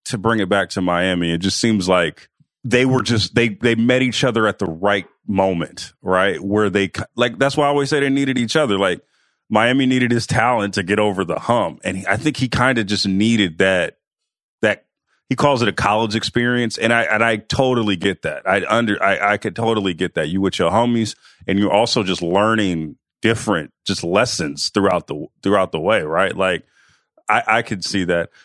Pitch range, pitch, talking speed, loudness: 100-120 Hz, 110 Hz, 215 wpm, -18 LUFS